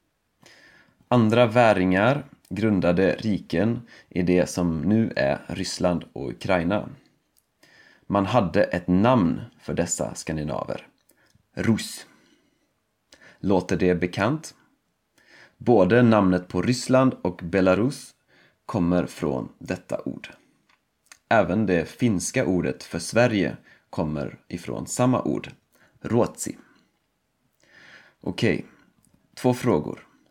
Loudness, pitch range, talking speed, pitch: -23 LUFS, 90-120 Hz, 95 wpm, 95 Hz